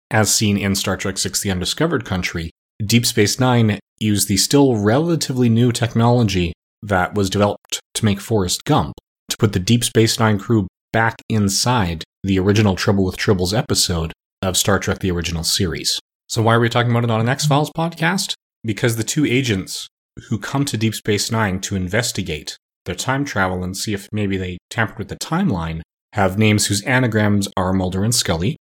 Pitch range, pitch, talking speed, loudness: 95-115 Hz, 105 Hz, 190 wpm, -18 LUFS